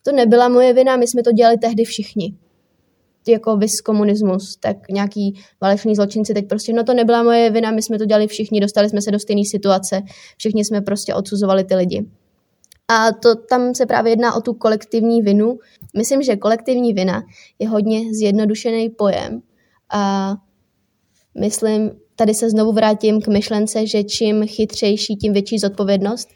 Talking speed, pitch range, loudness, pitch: 165 wpm, 205-230 Hz, -16 LUFS, 215 Hz